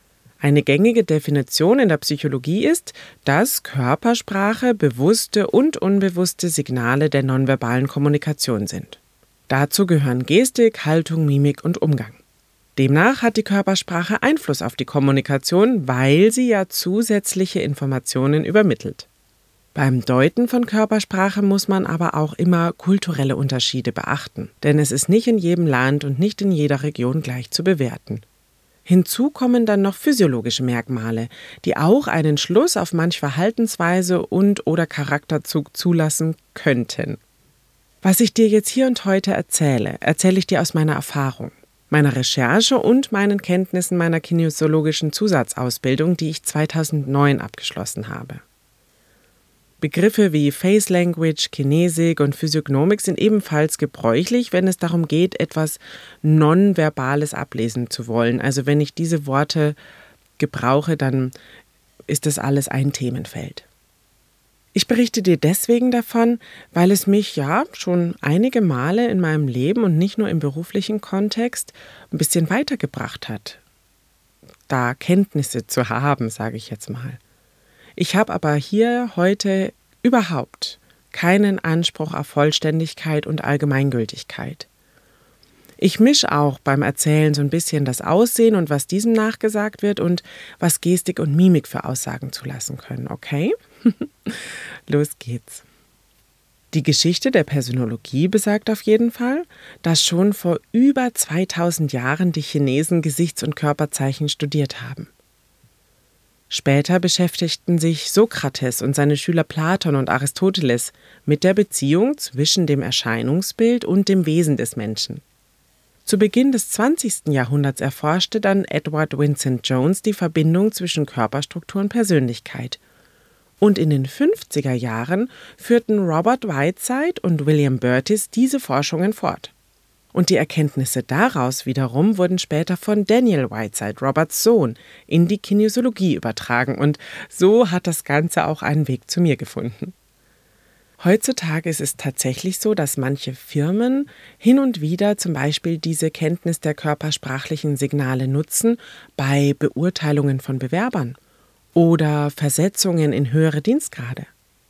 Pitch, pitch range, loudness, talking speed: 160 Hz, 140-195 Hz, -19 LUFS, 130 wpm